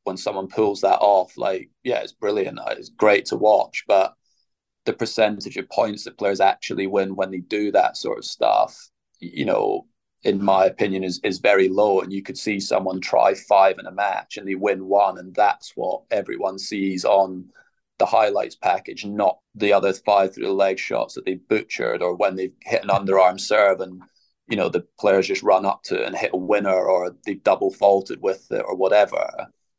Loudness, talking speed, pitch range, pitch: -21 LUFS, 200 wpm, 95-105 Hz, 95 Hz